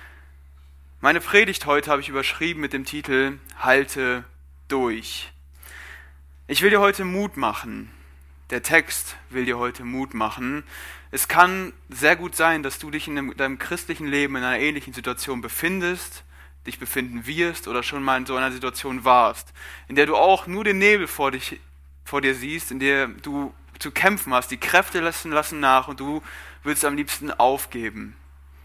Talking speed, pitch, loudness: 170 wpm, 130 Hz, -22 LUFS